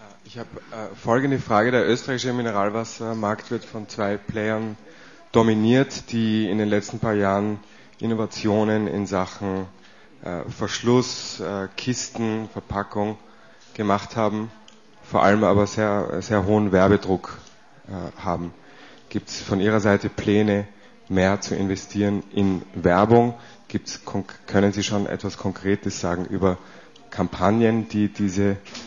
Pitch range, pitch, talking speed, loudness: 100-110 Hz, 105 Hz, 115 wpm, -23 LUFS